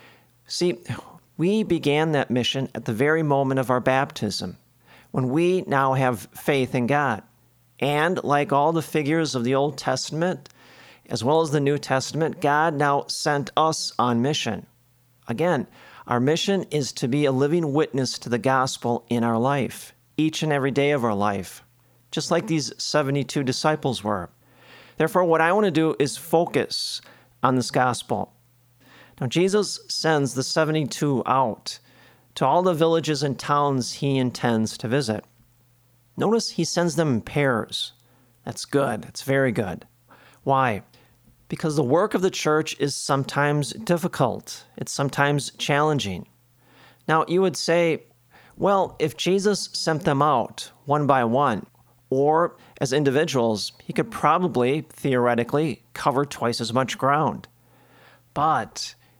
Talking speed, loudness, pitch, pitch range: 145 wpm, -23 LUFS, 140 Hz, 125-155 Hz